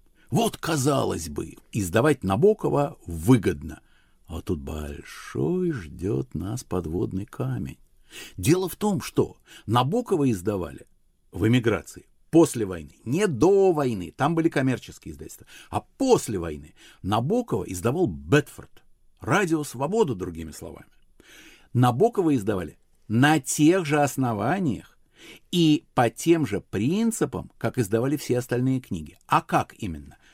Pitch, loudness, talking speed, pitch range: 125 Hz, -24 LUFS, 115 wpm, 90-155 Hz